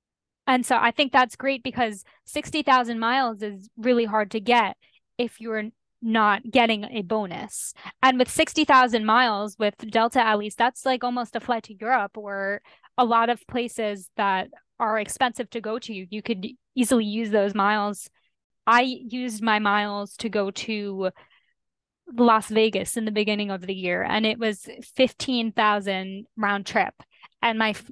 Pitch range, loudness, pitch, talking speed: 210-245 Hz, -24 LUFS, 225 Hz, 160 wpm